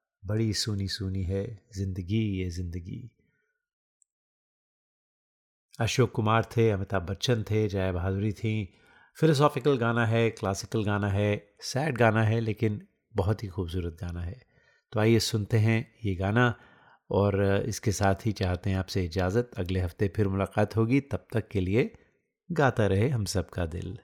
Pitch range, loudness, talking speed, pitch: 95-115 Hz, -28 LUFS, 145 wpm, 105 Hz